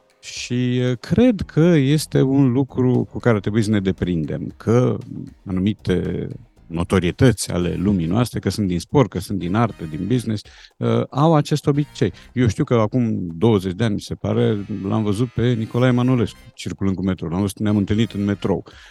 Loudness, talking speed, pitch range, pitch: -20 LUFS, 170 wpm, 100-125 Hz, 110 Hz